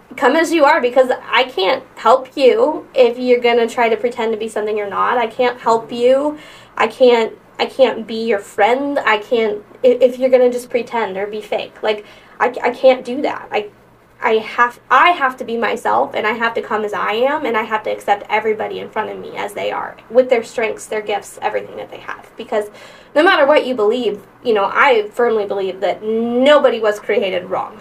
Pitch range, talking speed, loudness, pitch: 215-265 Hz, 225 wpm, -16 LUFS, 240 Hz